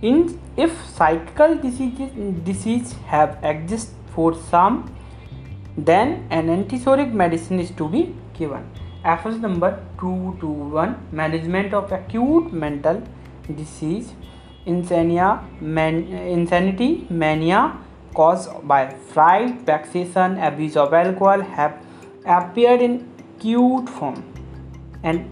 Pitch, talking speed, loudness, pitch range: 175 Hz, 95 wpm, -20 LUFS, 155-220 Hz